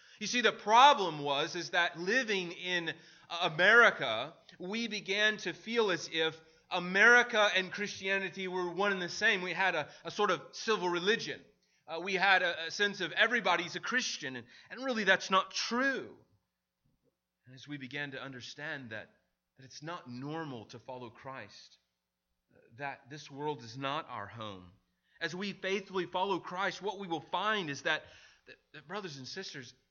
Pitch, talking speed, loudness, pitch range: 175 Hz, 170 wpm, -31 LUFS, 140-200 Hz